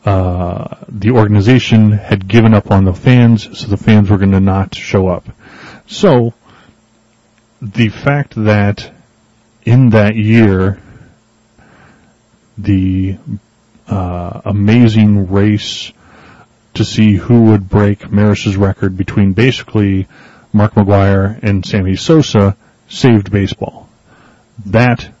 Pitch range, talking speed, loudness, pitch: 100-115 Hz, 105 wpm, -11 LUFS, 105 Hz